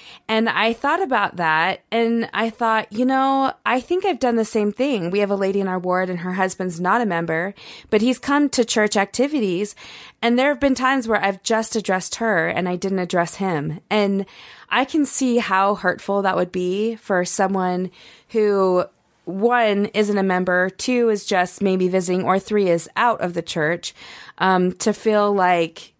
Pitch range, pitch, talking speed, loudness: 185-230 Hz, 205 Hz, 190 wpm, -20 LUFS